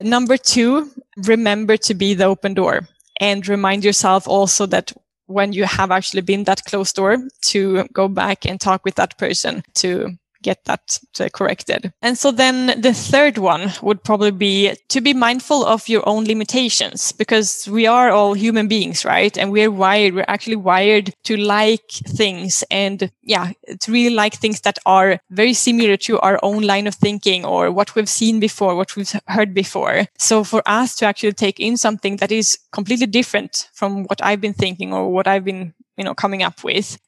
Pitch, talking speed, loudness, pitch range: 205 Hz, 190 wpm, -16 LUFS, 195-220 Hz